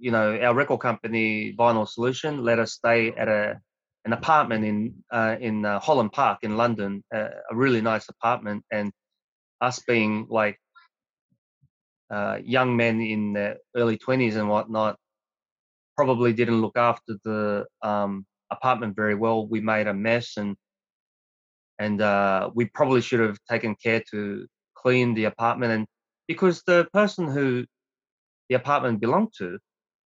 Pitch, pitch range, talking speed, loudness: 115 Hz, 105-120 Hz, 150 wpm, -24 LUFS